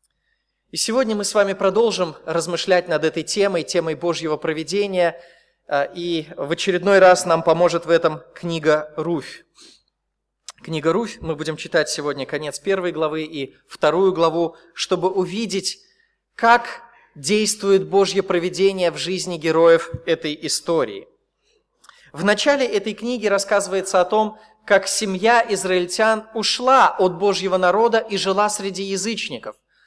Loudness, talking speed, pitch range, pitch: -19 LUFS, 130 wpm, 165-210 Hz, 185 Hz